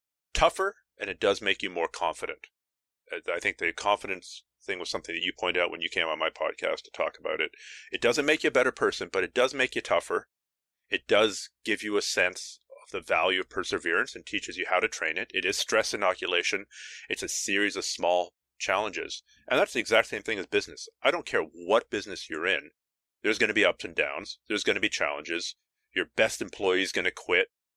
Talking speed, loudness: 225 wpm, -28 LUFS